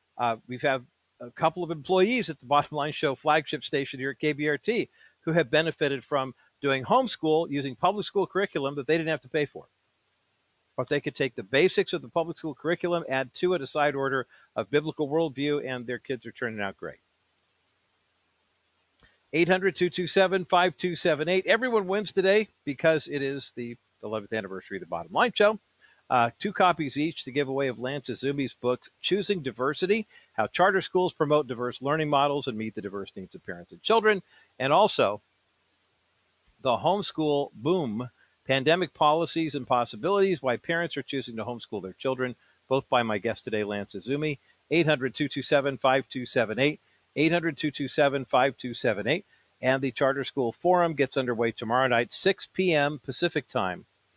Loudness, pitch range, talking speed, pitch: -27 LUFS, 125-170 Hz, 165 wpm, 140 Hz